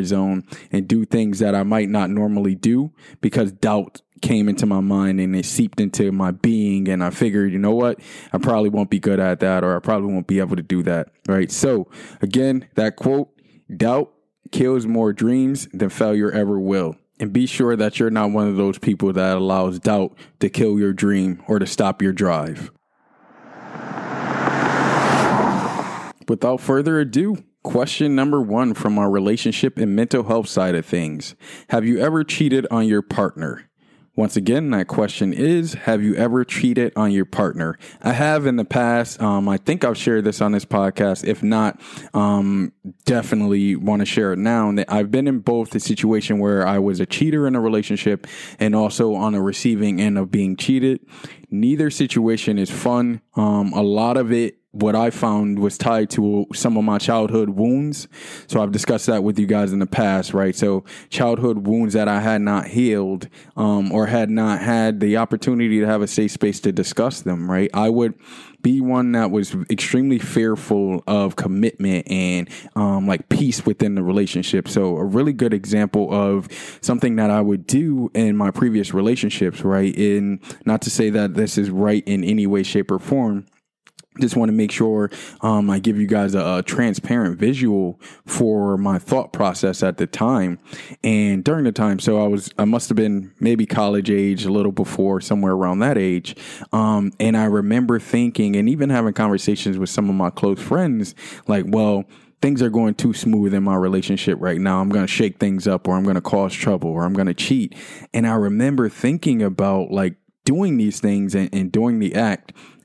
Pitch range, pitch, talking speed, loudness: 100-115 Hz, 105 Hz, 190 wpm, -19 LUFS